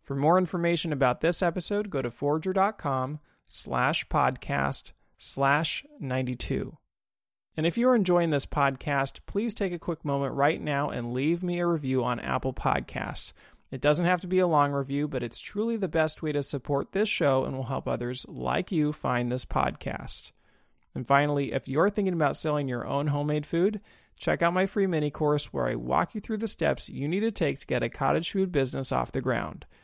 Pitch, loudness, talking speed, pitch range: 150 Hz, -28 LUFS, 195 wpm, 135-180 Hz